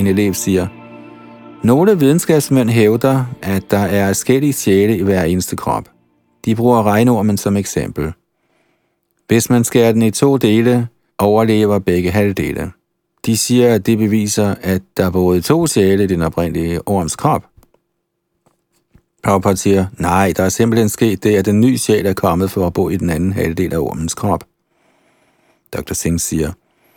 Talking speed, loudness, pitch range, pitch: 160 wpm, -15 LUFS, 95-115 Hz, 100 Hz